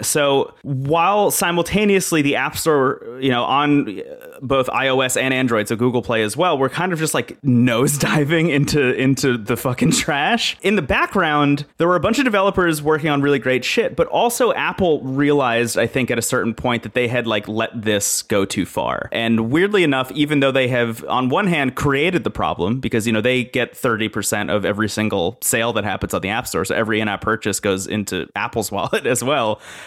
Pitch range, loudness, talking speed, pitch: 115-150 Hz, -18 LUFS, 205 wpm, 130 Hz